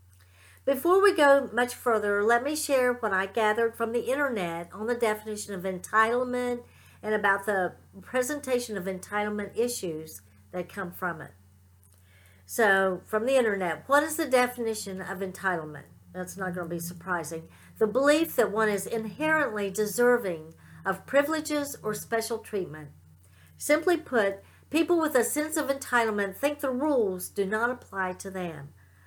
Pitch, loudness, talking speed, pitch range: 215 Hz, -27 LUFS, 155 wpm, 180-250 Hz